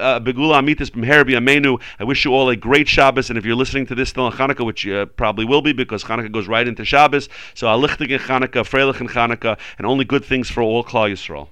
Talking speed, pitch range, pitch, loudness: 225 wpm, 115-135 Hz, 130 Hz, -17 LUFS